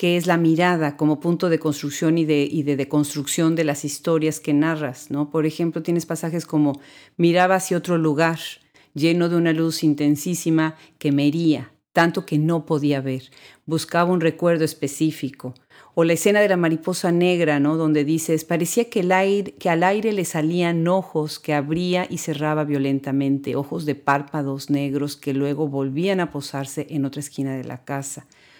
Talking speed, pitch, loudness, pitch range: 180 wpm, 155 Hz, -21 LUFS, 145-170 Hz